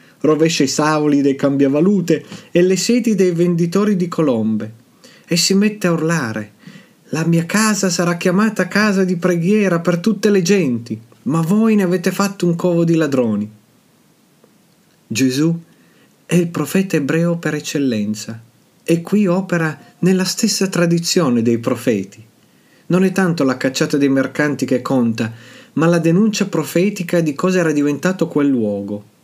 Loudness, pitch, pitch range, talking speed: -16 LUFS, 165 Hz, 135-185 Hz, 150 wpm